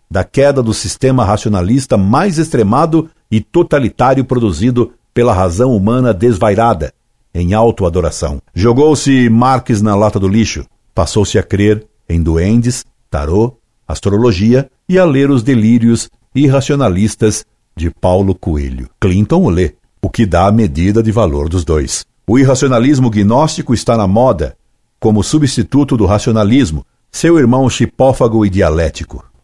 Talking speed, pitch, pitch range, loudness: 135 wpm, 110 Hz, 95-125 Hz, -12 LUFS